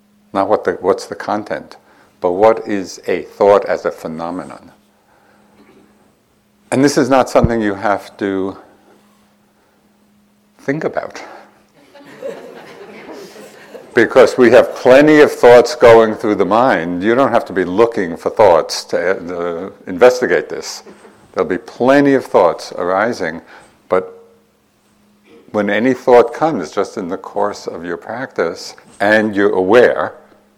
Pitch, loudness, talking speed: 130 Hz, -14 LUFS, 130 wpm